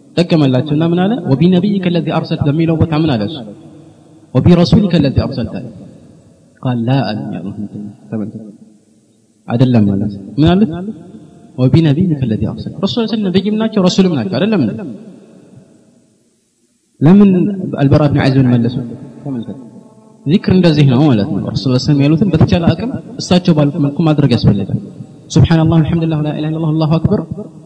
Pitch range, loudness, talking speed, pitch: 125-175 Hz, -13 LUFS, 155 wpm, 150 Hz